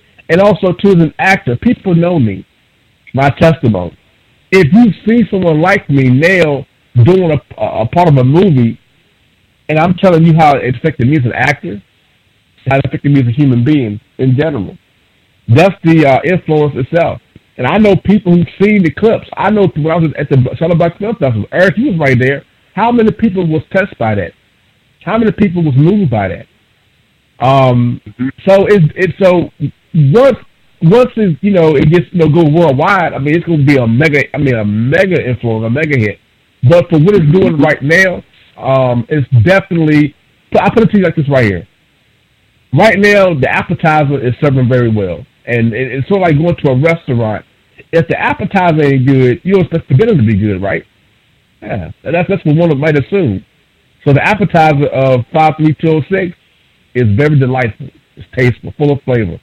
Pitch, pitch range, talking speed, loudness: 150 Hz, 125-175 Hz, 200 wpm, -10 LUFS